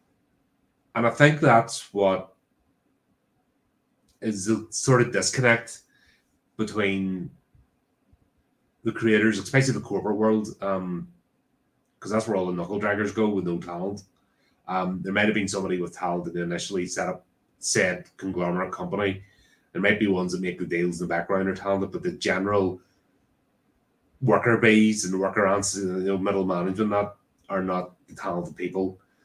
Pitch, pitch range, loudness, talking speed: 100 Hz, 90-110 Hz, -25 LUFS, 160 wpm